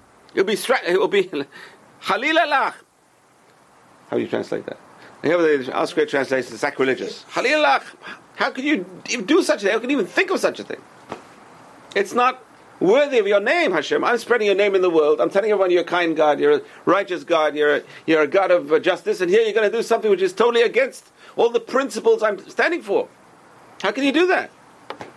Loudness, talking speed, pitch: -19 LUFS, 205 wpm, 225 Hz